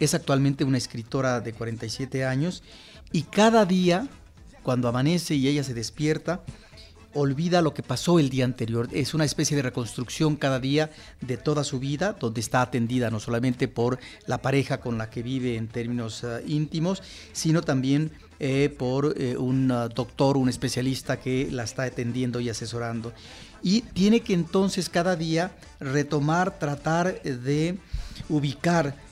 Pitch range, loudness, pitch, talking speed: 120-155 Hz, -26 LUFS, 135 Hz, 155 wpm